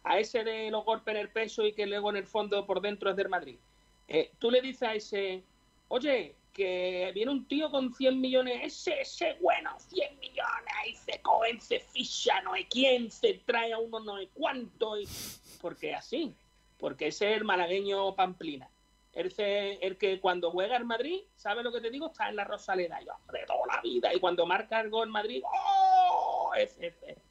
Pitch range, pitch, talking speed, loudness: 200-280 Hz, 225 Hz, 200 wpm, -31 LUFS